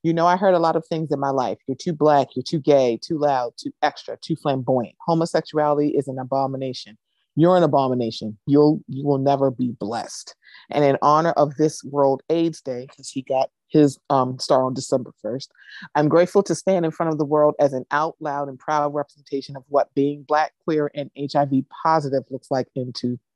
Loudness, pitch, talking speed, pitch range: -21 LUFS, 145 Hz, 205 wpm, 135-155 Hz